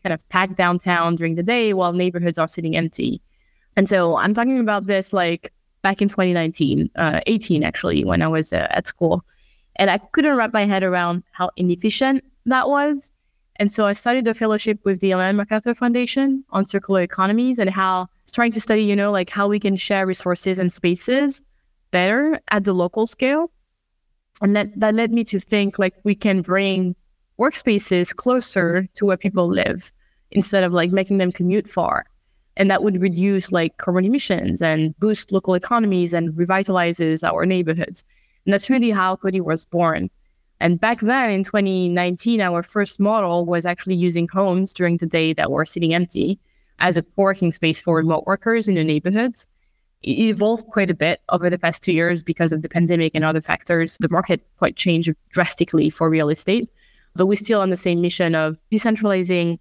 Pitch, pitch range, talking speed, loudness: 190 Hz, 175-210 Hz, 185 wpm, -19 LUFS